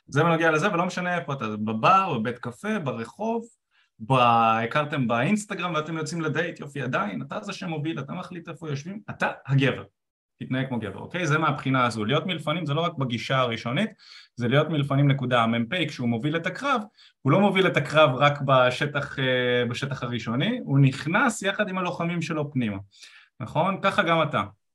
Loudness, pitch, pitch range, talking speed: -25 LUFS, 150 Hz, 125-175 Hz, 170 wpm